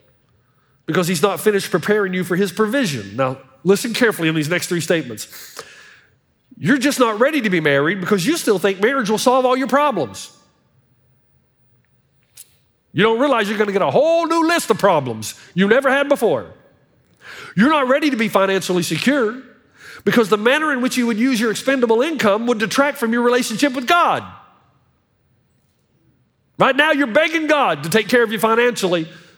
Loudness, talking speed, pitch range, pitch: -17 LUFS, 175 wpm, 170-260 Hz, 220 Hz